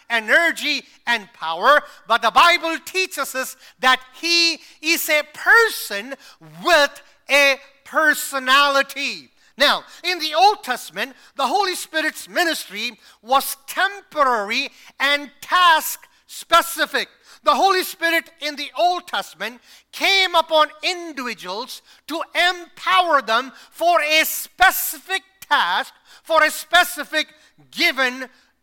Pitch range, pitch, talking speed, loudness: 260-335 Hz, 300 Hz, 105 wpm, -18 LUFS